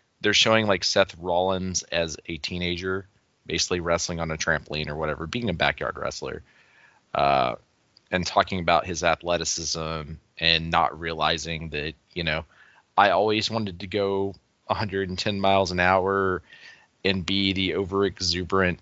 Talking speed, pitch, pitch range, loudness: 145 wpm, 90 Hz, 85-95 Hz, -25 LUFS